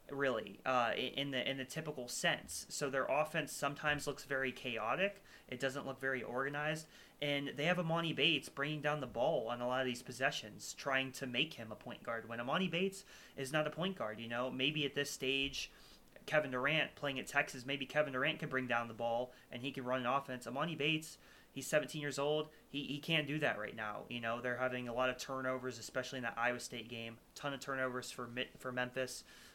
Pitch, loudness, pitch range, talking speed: 135 Hz, -38 LUFS, 125-150 Hz, 220 wpm